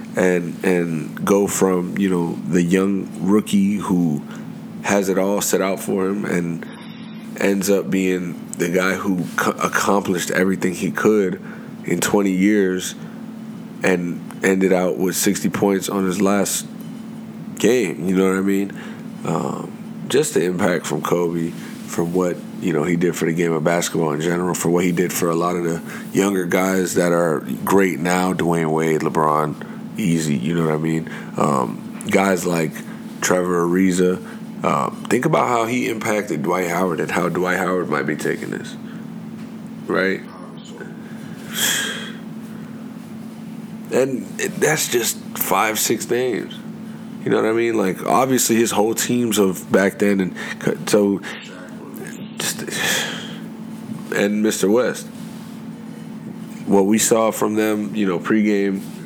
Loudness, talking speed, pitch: -19 LUFS, 145 wpm, 100 Hz